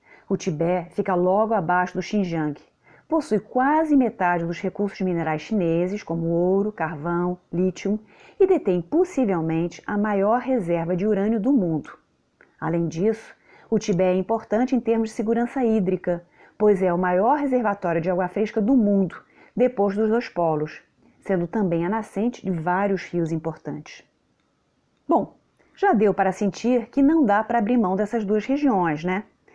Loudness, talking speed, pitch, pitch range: -23 LUFS, 155 wpm, 200 Hz, 175-225 Hz